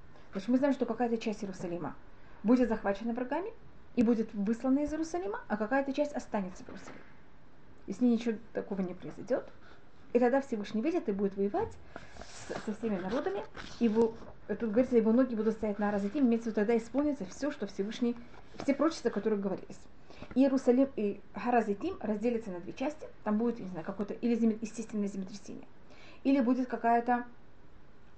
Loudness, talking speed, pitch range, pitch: -32 LUFS, 165 wpm, 210-255 Hz, 230 Hz